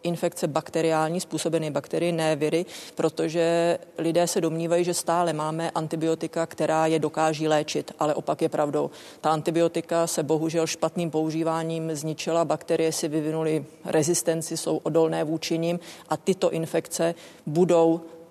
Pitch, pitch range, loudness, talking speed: 165 Hz, 160-170 Hz, -25 LUFS, 135 wpm